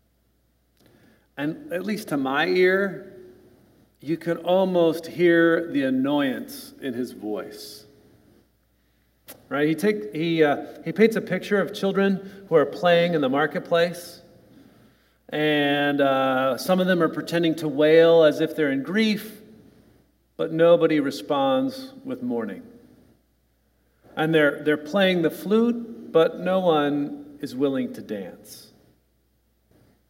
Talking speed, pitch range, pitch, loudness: 130 wpm, 145-195 Hz, 165 Hz, -22 LUFS